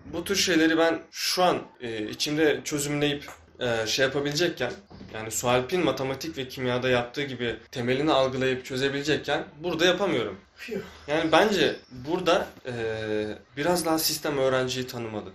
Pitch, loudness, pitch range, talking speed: 135 Hz, -26 LUFS, 125-160 Hz, 130 wpm